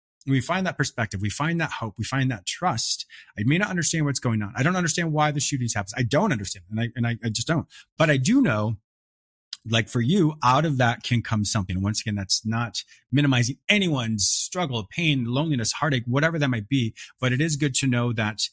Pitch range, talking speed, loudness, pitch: 110-150 Hz, 225 wpm, -24 LUFS, 125 Hz